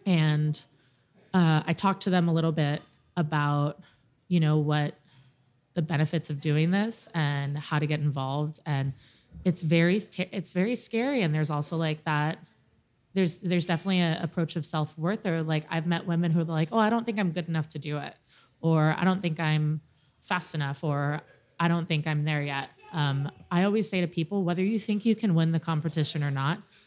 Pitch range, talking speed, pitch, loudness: 150-180 Hz, 200 wpm, 160 Hz, -28 LUFS